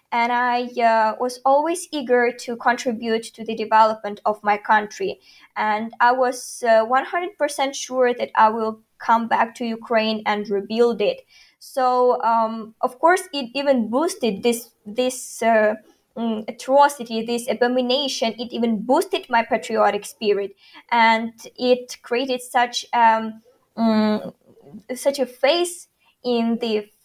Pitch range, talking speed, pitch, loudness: 225-255 Hz, 140 wpm, 240 Hz, -21 LUFS